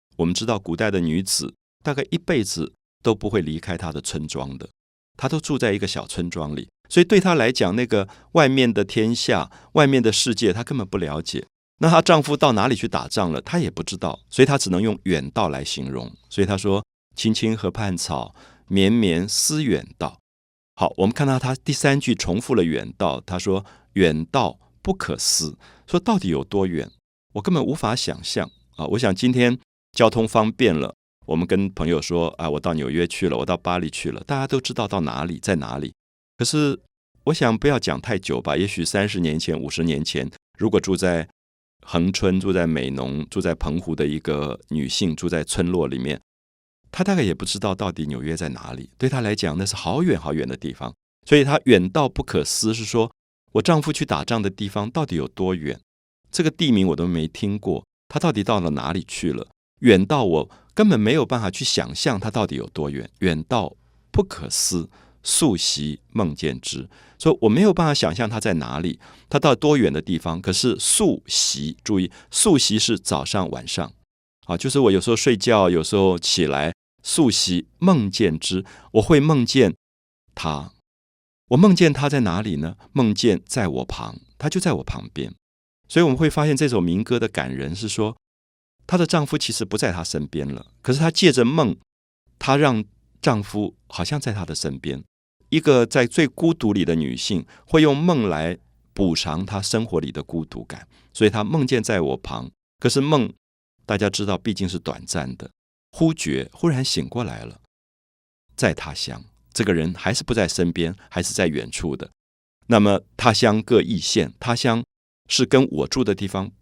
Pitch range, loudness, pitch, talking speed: 80-125 Hz, -21 LUFS, 100 Hz, 270 characters per minute